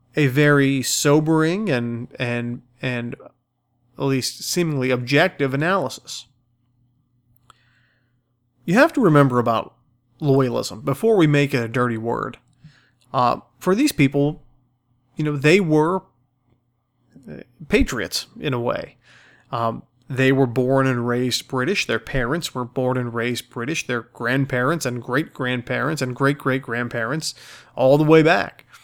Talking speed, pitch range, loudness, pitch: 130 wpm, 120-145 Hz, -20 LUFS, 130 Hz